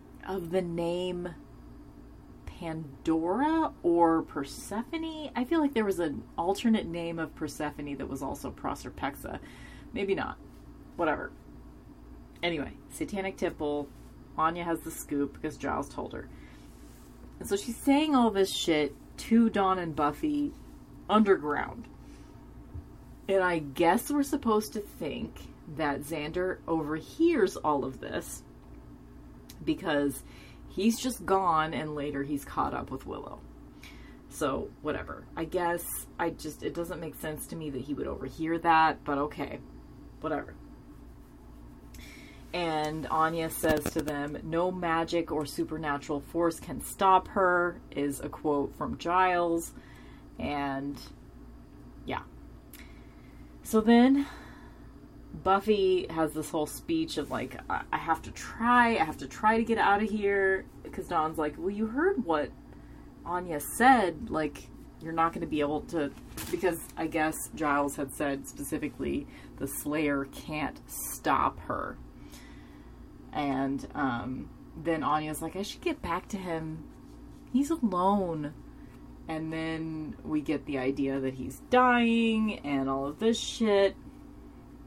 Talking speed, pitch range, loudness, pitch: 135 wpm, 145-195 Hz, -30 LUFS, 160 Hz